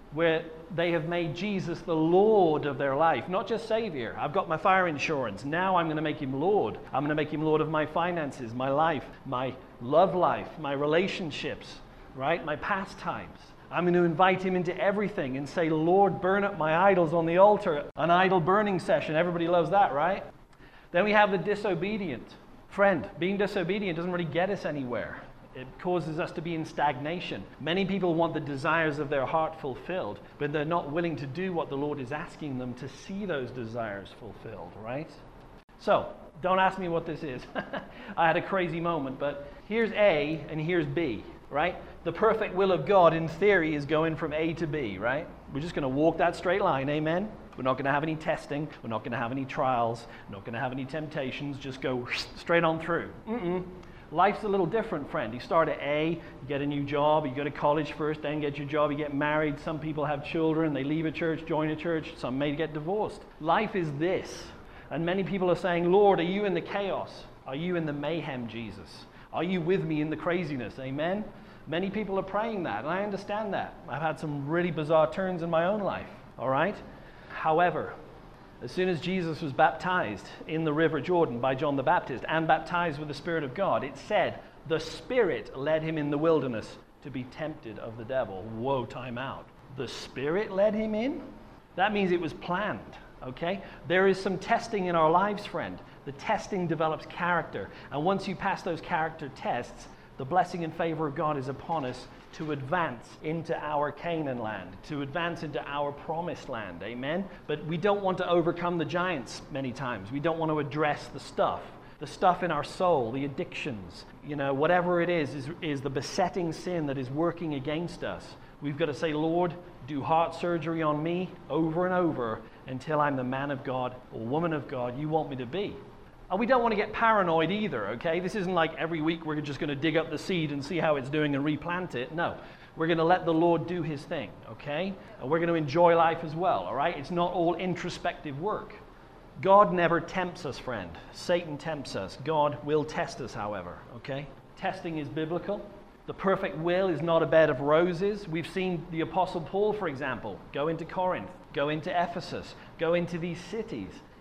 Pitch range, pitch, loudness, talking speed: 145-180 Hz, 165 Hz, -29 LUFS, 210 wpm